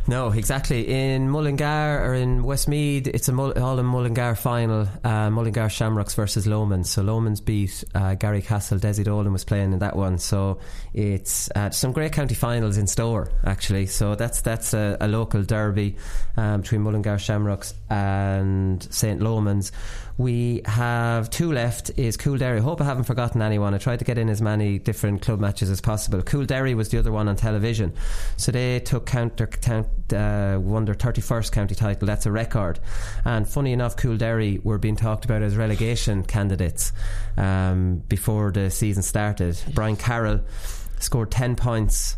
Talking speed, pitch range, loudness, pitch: 175 wpm, 100-120 Hz, -24 LUFS, 110 Hz